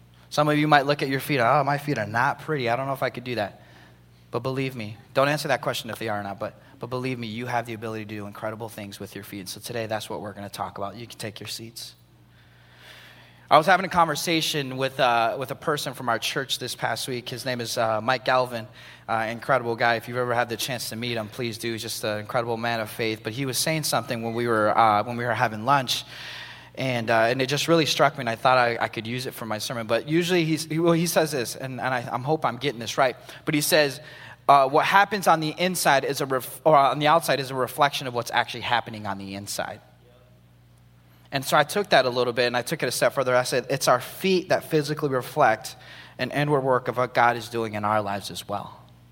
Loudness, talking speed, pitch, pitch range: -24 LUFS, 265 wpm, 120 Hz, 110-140 Hz